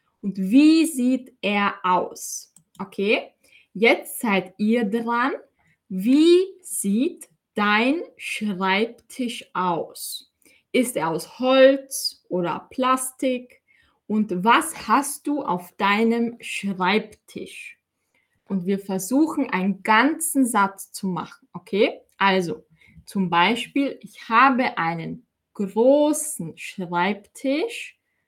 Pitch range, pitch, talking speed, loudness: 195-265 Hz, 225 Hz, 95 wpm, -22 LUFS